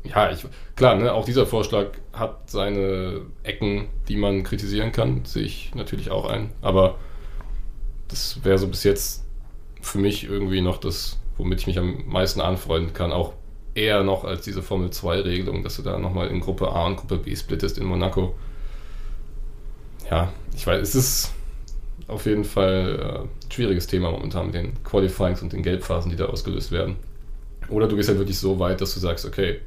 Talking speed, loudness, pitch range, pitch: 180 wpm, -24 LUFS, 90-105 Hz, 95 Hz